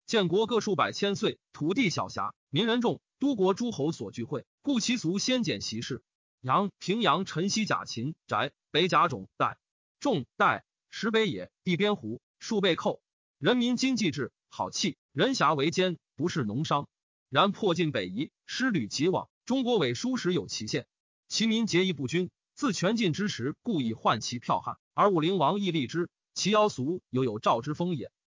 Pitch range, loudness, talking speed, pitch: 140-215 Hz, -29 LUFS, 250 characters per minute, 180 Hz